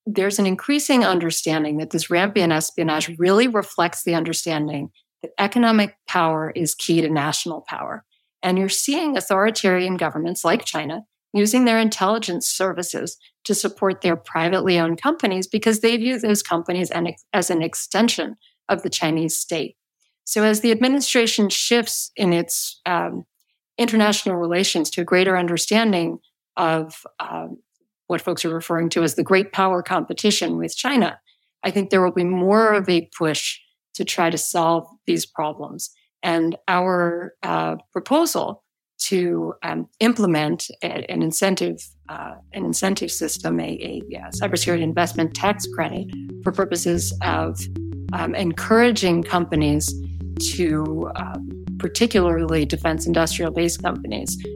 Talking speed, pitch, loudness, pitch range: 135 wpm, 175 Hz, -21 LUFS, 160-200 Hz